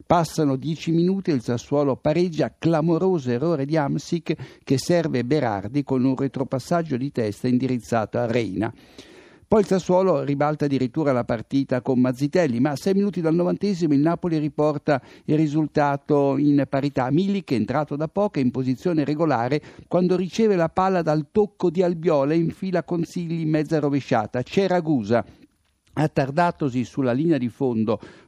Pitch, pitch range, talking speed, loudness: 150 Hz, 135-175 Hz, 155 wpm, -22 LUFS